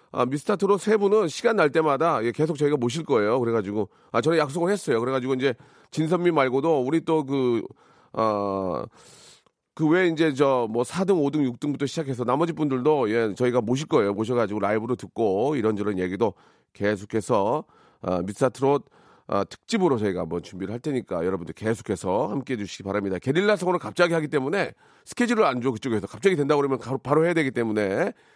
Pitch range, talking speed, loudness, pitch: 110-160 Hz, 415 characters per minute, -24 LUFS, 135 Hz